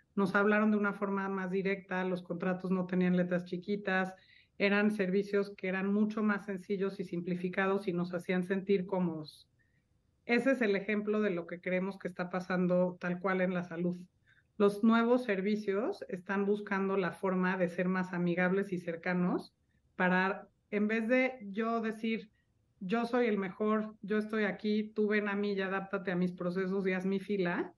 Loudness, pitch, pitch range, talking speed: -33 LUFS, 195 Hz, 180-205 Hz, 175 wpm